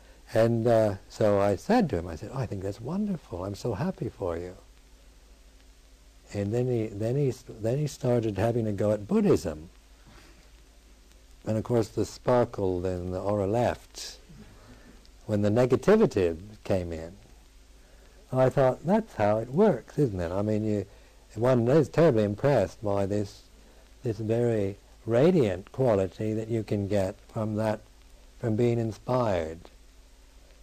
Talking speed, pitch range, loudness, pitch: 150 wpm, 90-120 Hz, -27 LUFS, 105 Hz